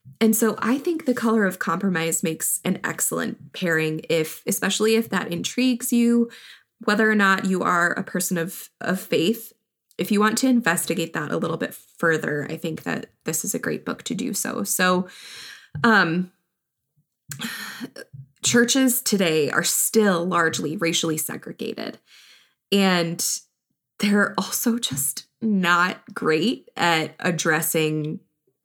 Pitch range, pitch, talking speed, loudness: 165-225 Hz, 185 Hz, 140 wpm, -22 LUFS